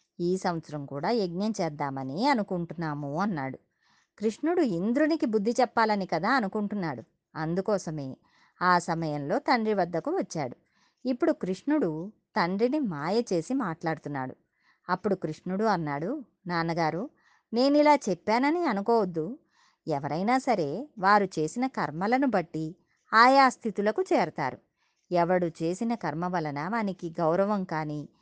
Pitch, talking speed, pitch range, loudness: 190 Hz, 100 wpm, 165-235 Hz, -28 LUFS